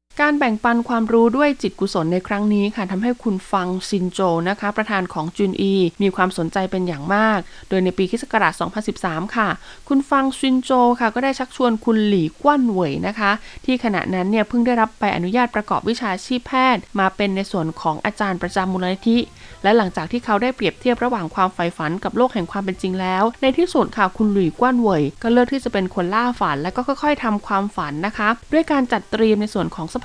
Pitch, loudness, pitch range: 210 Hz, -19 LUFS, 185-240 Hz